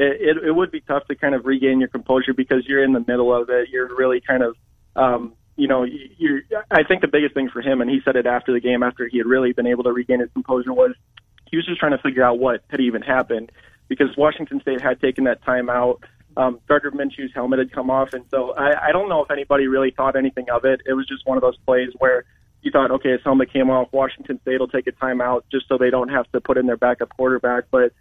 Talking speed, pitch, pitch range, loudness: 265 wpm, 130 Hz, 125-135 Hz, -20 LUFS